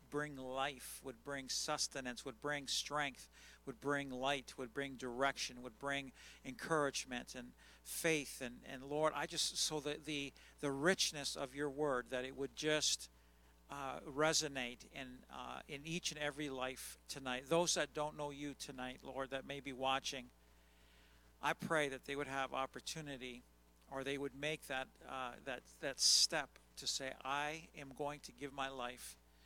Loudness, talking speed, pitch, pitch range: -41 LUFS, 165 wpm, 135 Hz, 125-145 Hz